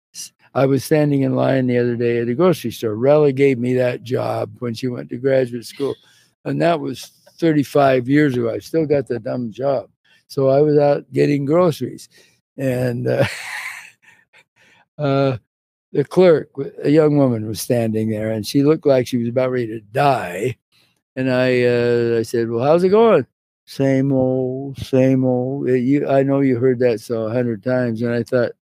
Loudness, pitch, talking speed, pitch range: -18 LUFS, 130 Hz, 185 wpm, 120-140 Hz